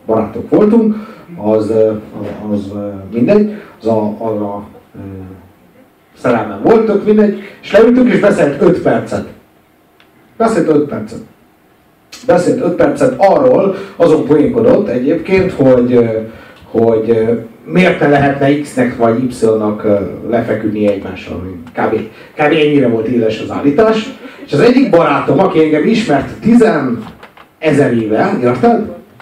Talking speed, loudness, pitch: 115 wpm, -12 LUFS, 140 Hz